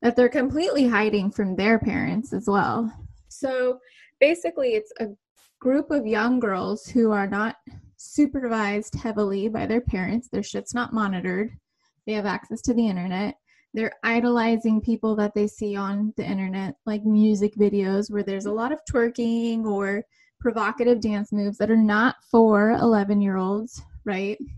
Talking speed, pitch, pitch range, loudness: 160 wpm, 220 Hz, 205-240 Hz, -24 LUFS